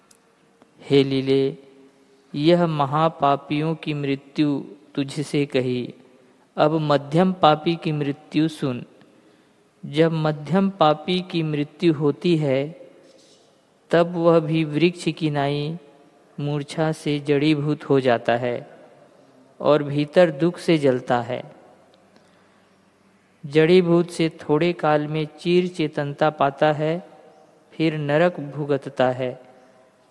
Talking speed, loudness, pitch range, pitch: 105 wpm, -21 LUFS, 140-165 Hz, 150 Hz